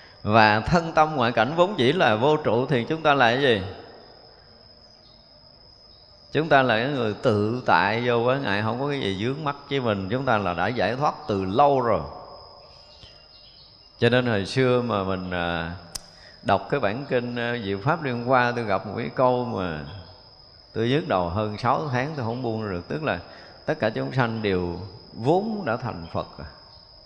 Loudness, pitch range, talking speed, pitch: -23 LUFS, 100-130 Hz, 190 wpm, 120 Hz